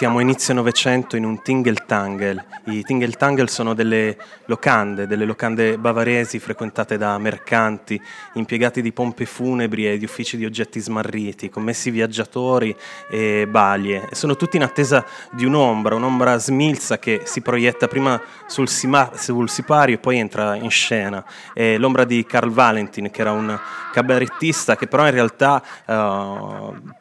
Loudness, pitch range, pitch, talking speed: -19 LUFS, 110-125 Hz, 115 Hz, 150 wpm